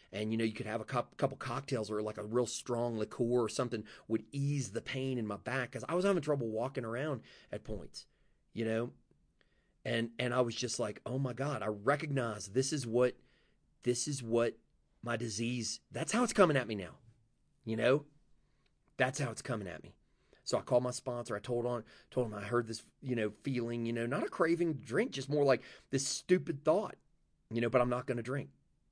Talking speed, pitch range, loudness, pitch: 220 wpm, 115-135 Hz, -35 LUFS, 125 Hz